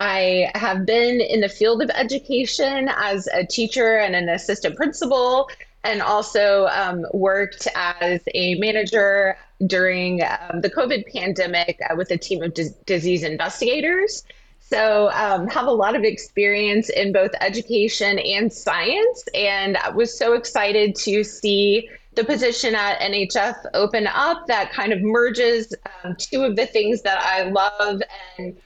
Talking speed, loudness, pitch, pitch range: 155 wpm, -20 LUFS, 205 Hz, 190-235 Hz